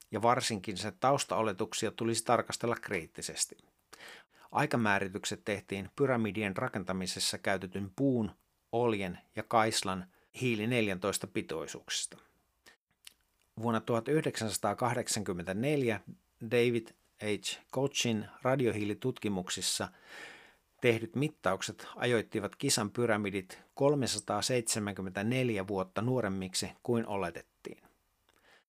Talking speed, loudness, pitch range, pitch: 75 wpm, -33 LUFS, 100-120 Hz, 110 Hz